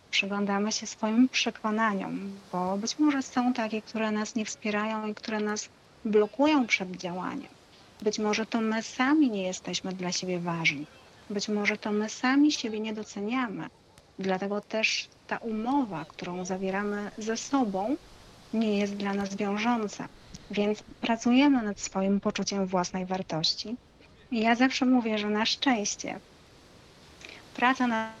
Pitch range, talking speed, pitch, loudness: 200-235 Hz, 140 wpm, 215 Hz, -28 LUFS